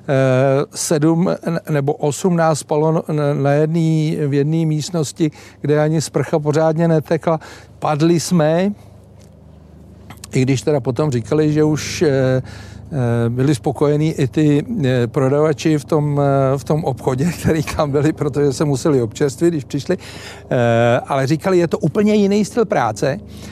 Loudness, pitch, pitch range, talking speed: -17 LUFS, 150 Hz, 130-160 Hz, 130 wpm